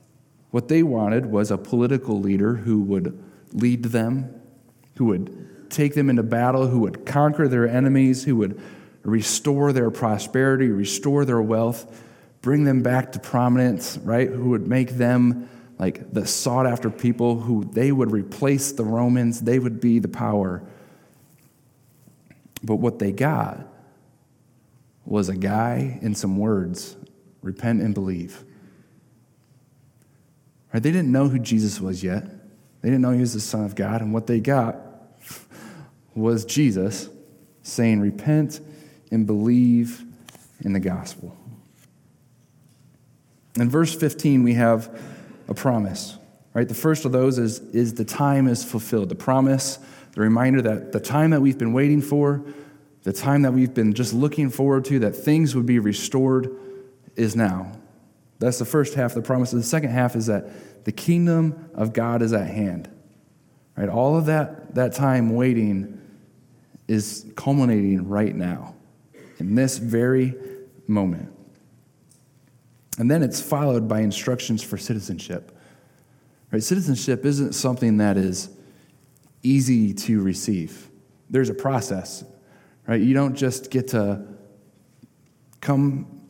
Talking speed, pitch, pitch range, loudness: 140 wpm, 125 Hz, 110-135 Hz, -22 LUFS